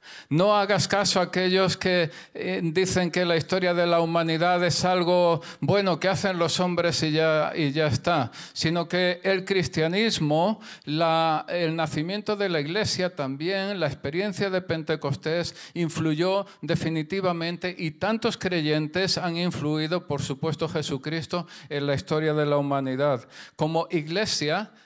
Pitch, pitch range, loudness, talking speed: 170 Hz, 155-185 Hz, -25 LUFS, 140 wpm